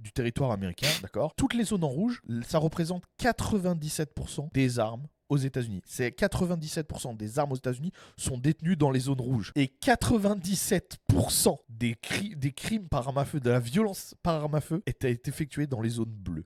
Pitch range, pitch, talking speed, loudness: 125-170 Hz, 145 Hz, 185 wpm, -29 LUFS